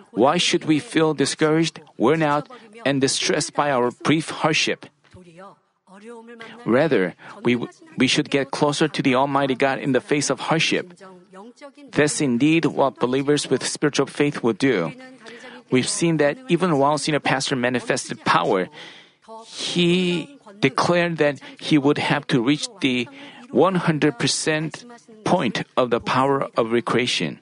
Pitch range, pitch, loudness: 135-180 Hz, 150 Hz, -21 LUFS